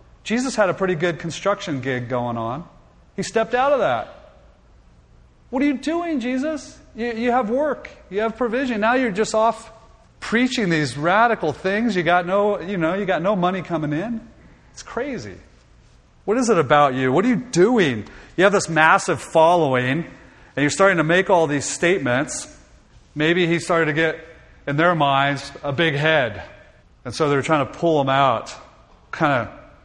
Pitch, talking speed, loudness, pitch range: 175 Hz, 180 wpm, -20 LUFS, 145-225 Hz